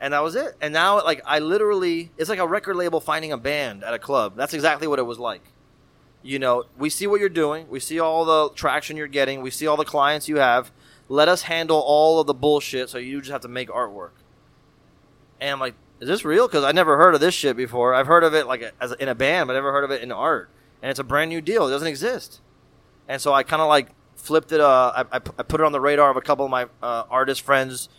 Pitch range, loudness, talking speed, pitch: 135-160 Hz, -21 LUFS, 270 wpm, 145 Hz